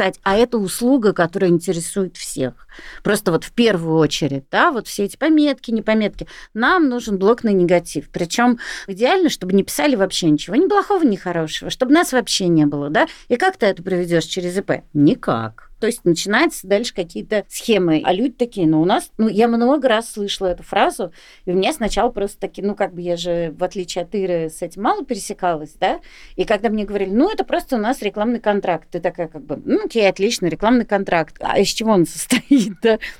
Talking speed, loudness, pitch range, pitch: 200 wpm, -18 LUFS, 175-235 Hz, 200 Hz